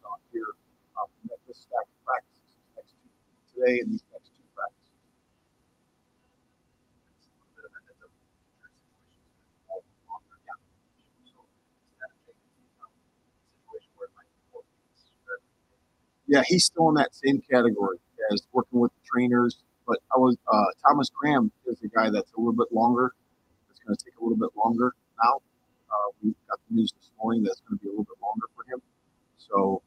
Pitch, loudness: 145 Hz, -26 LUFS